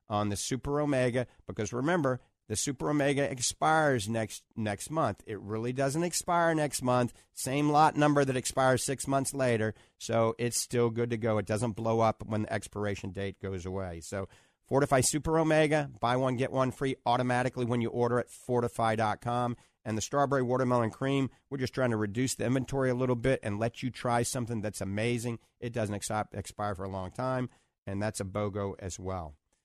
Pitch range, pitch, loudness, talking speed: 105-130 Hz, 120 Hz, -31 LUFS, 190 wpm